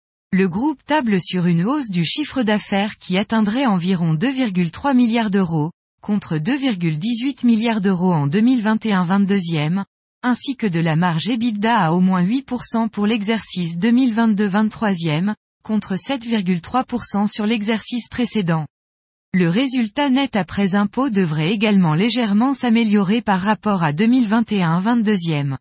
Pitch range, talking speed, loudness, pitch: 185-235 Hz, 120 wpm, -19 LUFS, 210 Hz